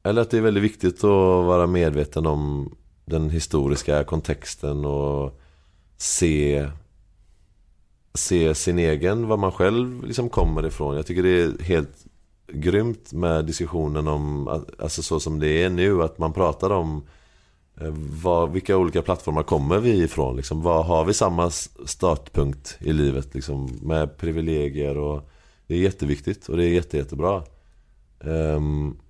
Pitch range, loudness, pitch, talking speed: 75-90 Hz, -23 LUFS, 80 Hz, 145 wpm